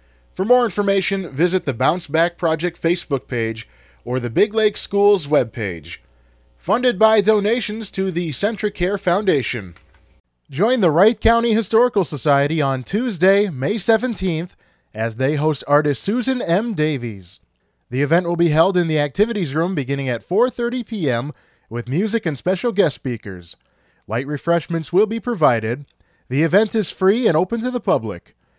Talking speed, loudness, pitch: 155 wpm, -19 LUFS, 165 Hz